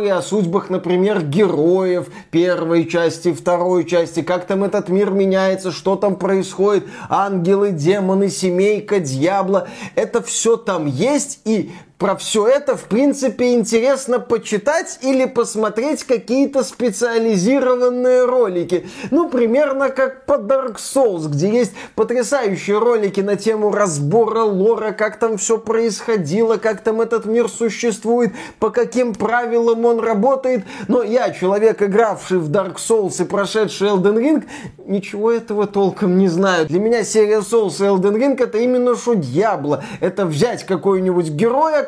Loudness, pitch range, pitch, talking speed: -17 LUFS, 190-240 Hz, 215 Hz, 140 wpm